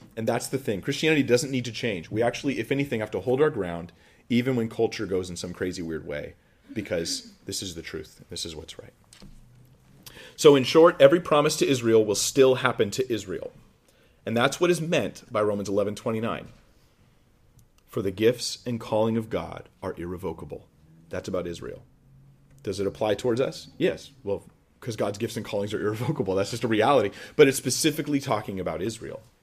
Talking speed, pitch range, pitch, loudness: 190 wpm, 105-135 Hz, 120 Hz, -25 LUFS